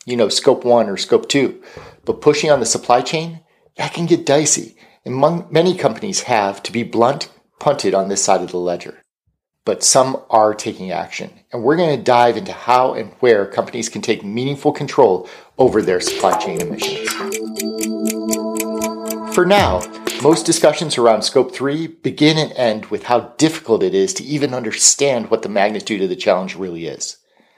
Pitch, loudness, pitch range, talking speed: 125 Hz, -17 LUFS, 110-160 Hz, 175 wpm